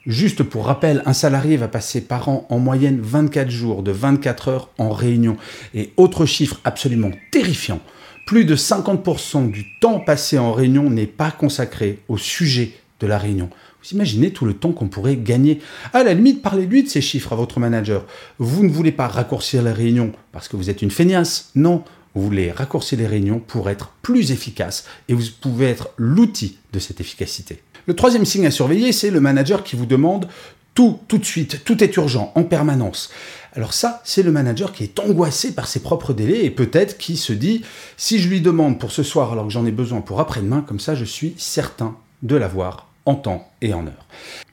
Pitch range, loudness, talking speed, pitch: 115-165 Hz, -18 LUFS, 205 wpm, 135 Hz